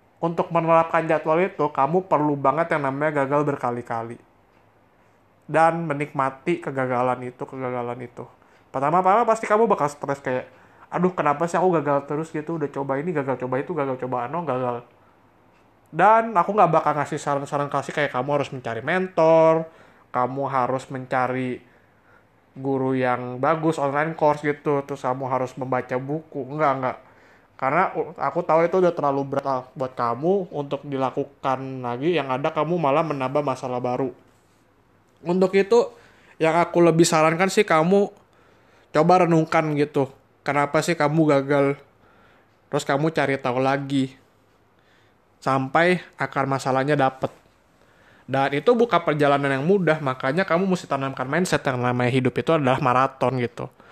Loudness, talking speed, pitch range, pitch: -22 LUFS, 145 wpm, 130-160 Hz, 140 Hz